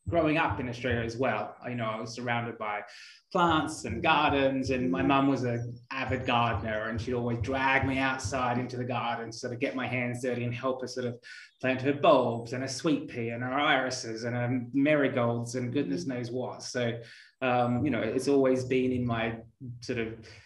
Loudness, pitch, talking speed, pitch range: -29 LUFS, 125 Hz, 210 wpm, 120-130 Hz